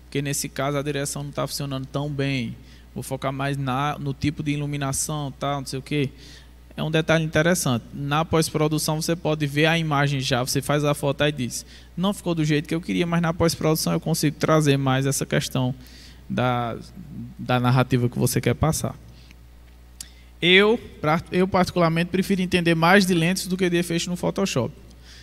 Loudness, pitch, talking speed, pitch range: -23 LUFS, 145 Hz, 190 wpm, 130-165 Hz